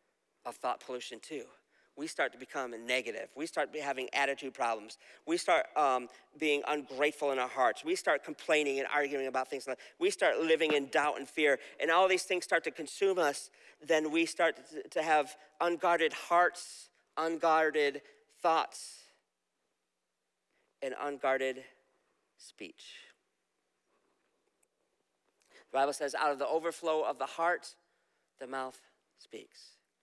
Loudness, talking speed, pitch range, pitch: -32 LUFS, 140 wpm, 140-185 Hz, 155 Hz